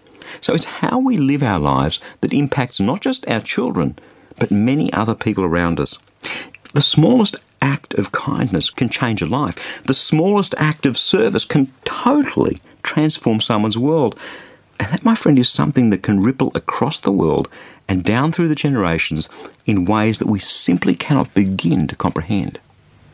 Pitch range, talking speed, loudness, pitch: 100-155 Hz, 165 wpm, -17 LUFS, 130 Hz